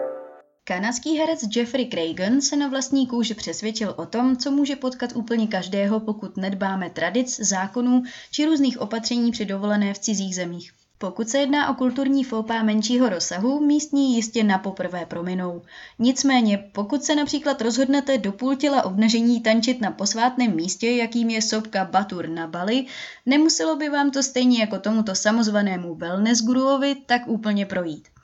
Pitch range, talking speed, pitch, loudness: 195-260 Hz, 155 wpm, 230 Hz, -22 LUFS